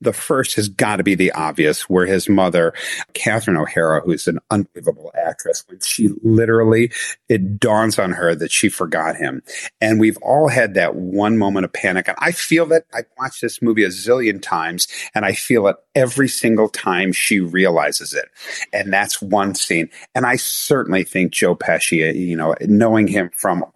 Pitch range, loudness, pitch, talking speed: 95-120 Hz, -17 LUFS, 105 Hz, 185 wpm